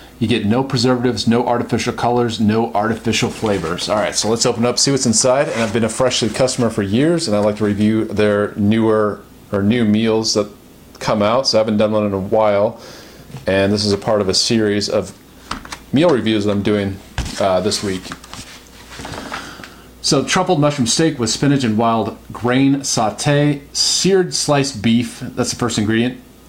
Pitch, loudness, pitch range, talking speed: 115 Hz, -16 LUFS, 105-125 Hz, 190 wpm